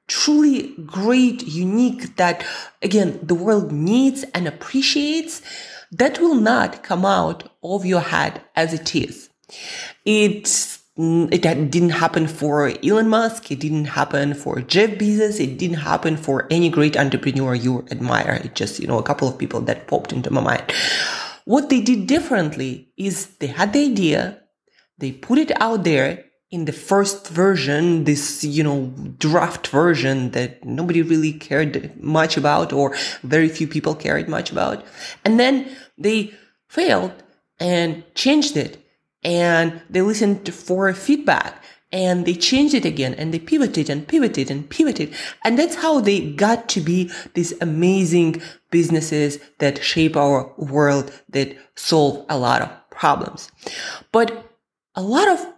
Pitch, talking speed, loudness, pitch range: 175 Hz, 150 wpm, -19 LUFS, 150-220 Hz